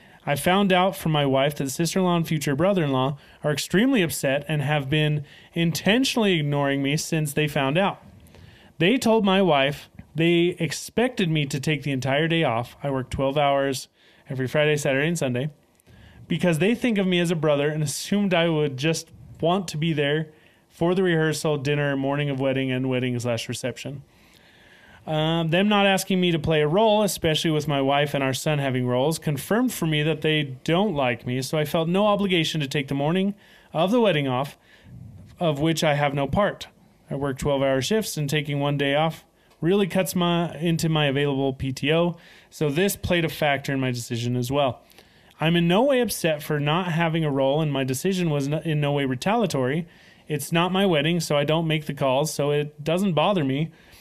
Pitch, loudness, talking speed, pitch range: 155 Hz, -23 LUFS, 200 wpm, 140-175 Hz